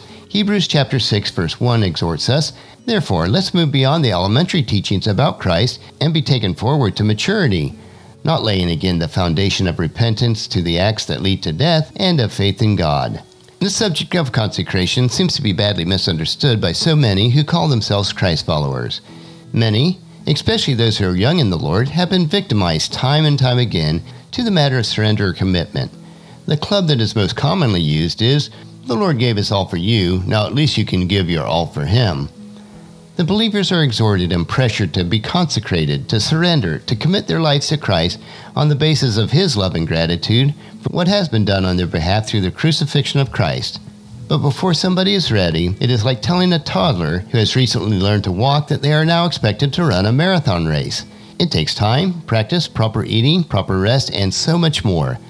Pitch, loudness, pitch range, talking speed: 120 Hz, -16 LUFS, 100-155 Hz, 200 wpm